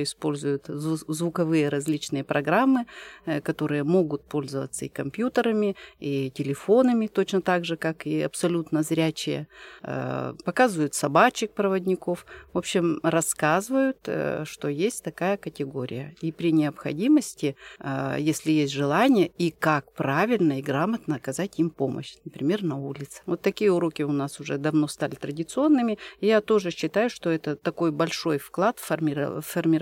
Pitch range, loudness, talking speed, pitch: 145-185 Hz, -25 LUFS, 125 wpm, 160 Hz